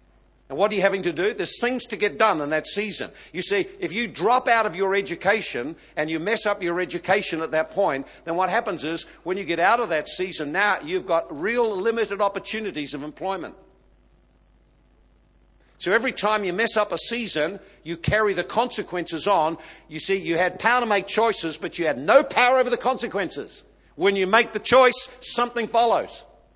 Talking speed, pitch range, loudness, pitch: 200 wpm, 170-235 Hz, -23 LUFS, 200 Hz